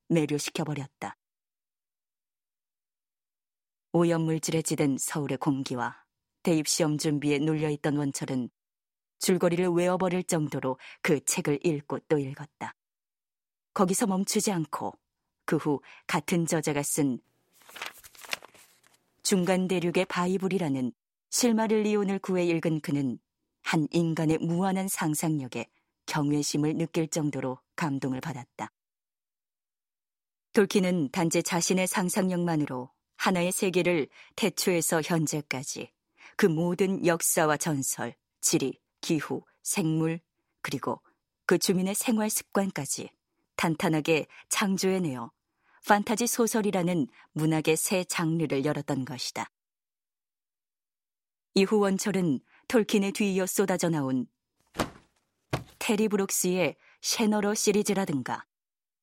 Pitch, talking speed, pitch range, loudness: 170 Hz, 240 characters per minute, 150-190 Hz, -28 LUFS